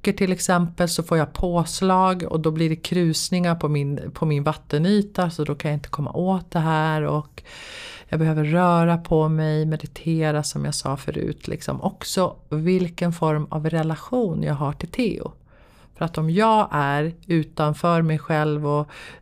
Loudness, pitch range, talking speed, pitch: -22 LUFS, 150-180 Hz, 170 wpm, 160 Hz